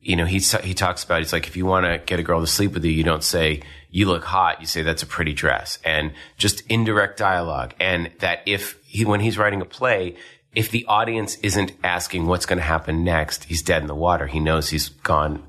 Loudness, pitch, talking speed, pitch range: -21 LUFS, 90 Hz, 245 wpm, 80-100 Hz